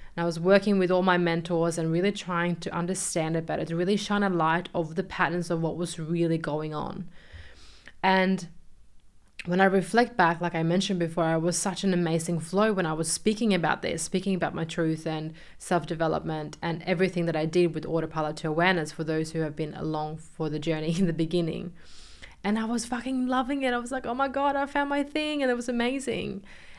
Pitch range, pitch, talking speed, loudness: 165-195 Hz, 175 Hz, 215 wpm, -27 LUFS